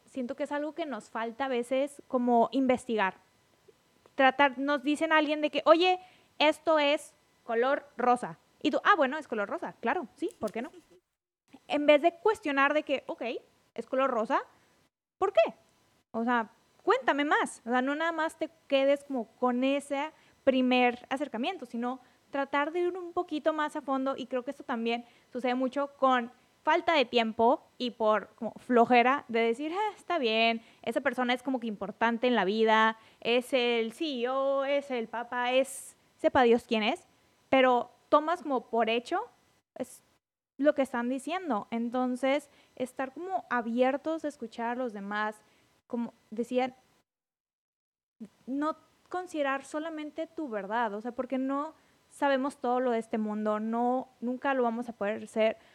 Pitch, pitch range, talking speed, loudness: 260 Hz, 235-300 Hz, 170 wpm, -29 LUFS